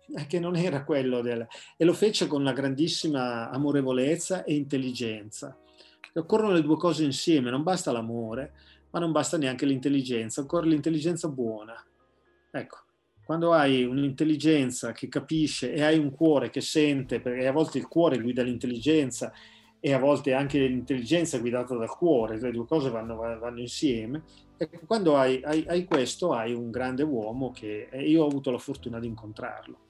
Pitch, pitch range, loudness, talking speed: 135 Hz, 125-155 Hz, -27 LUFS, 165 wpm